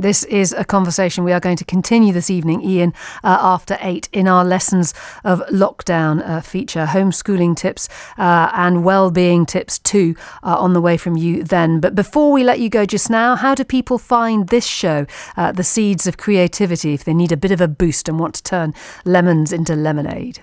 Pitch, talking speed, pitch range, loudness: 180 Hz, 205 wpm, 170-200 Hz, -16 LUFS